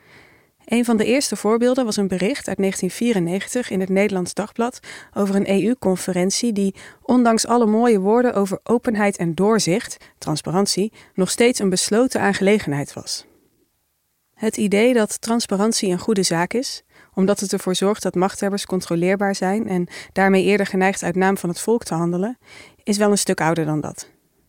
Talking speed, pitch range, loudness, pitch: 165 wpm, 185-225 Hz, -20 LUFS, 200 Hz